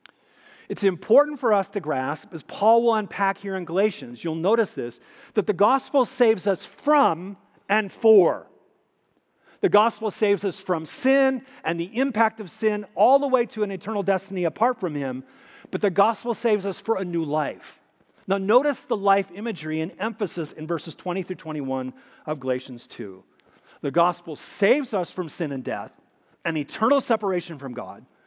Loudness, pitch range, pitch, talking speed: -24 LUFS, 165-225 Hz, 195 Hz, 175 wpm